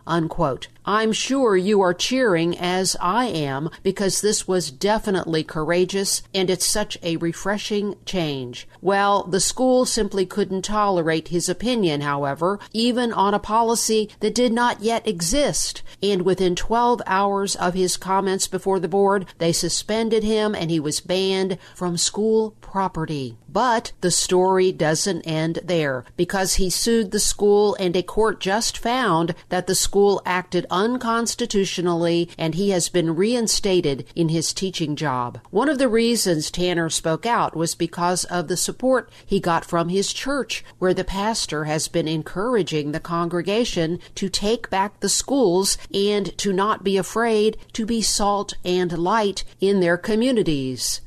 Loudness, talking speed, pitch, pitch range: -21 LUFS, 155 wpm, 190 Hz, 170-210 Hz